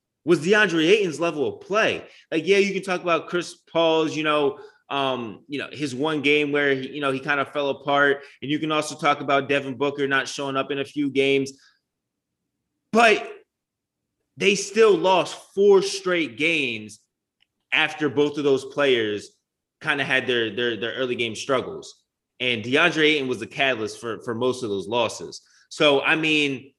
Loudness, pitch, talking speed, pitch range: -22 LUFS, 145 Hz, 185 wpm, 135-160 Hz